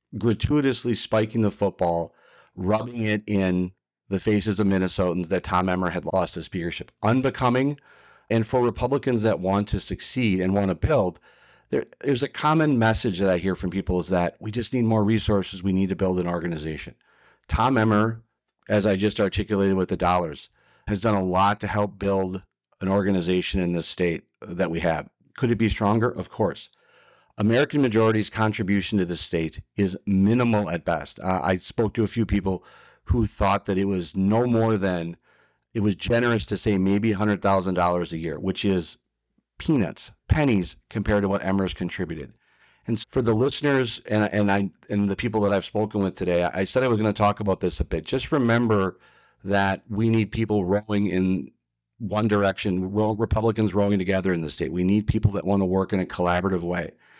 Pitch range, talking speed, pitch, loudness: 95-110 Hz, 190 wpm, 100 Hz, -24 LUFS